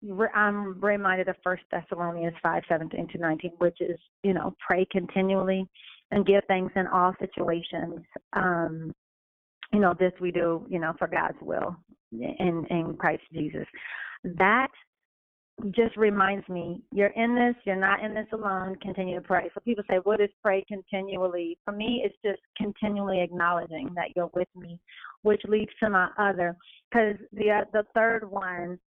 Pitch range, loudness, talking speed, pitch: 175-205 Hz, -27 LUFS, 160 wpm, 190 Hz